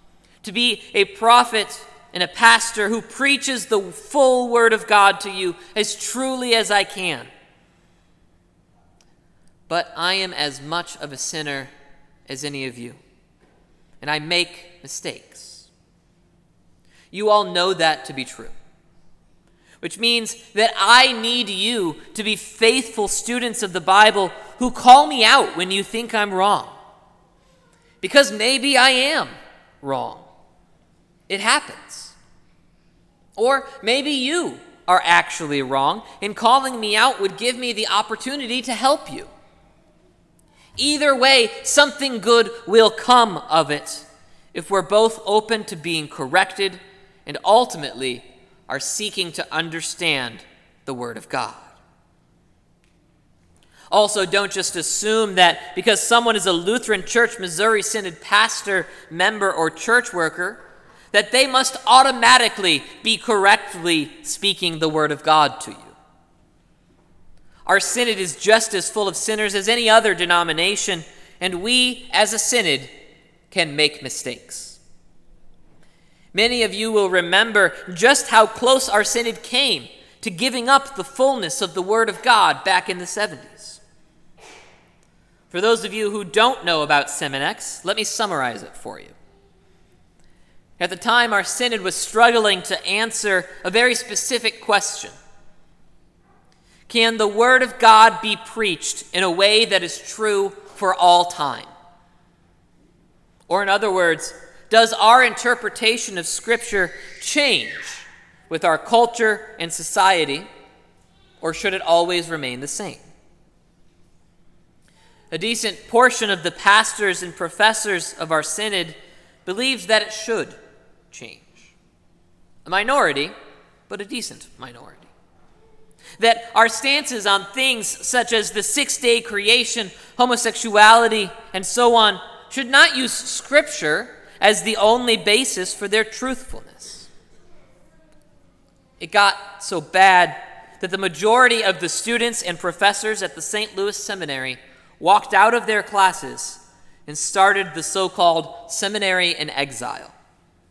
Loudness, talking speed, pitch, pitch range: -18 LUFS, 135 wpm, 205 Hz, 175-230 Hz